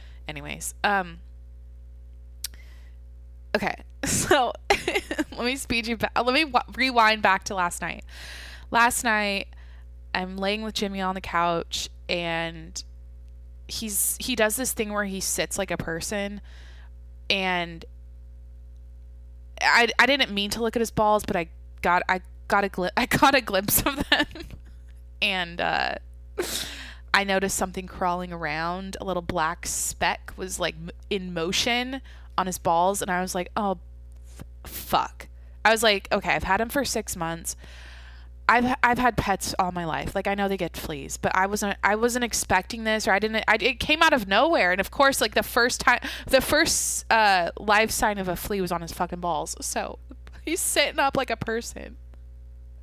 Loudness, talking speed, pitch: -24 LUFS, 175 wpm, 180 Hz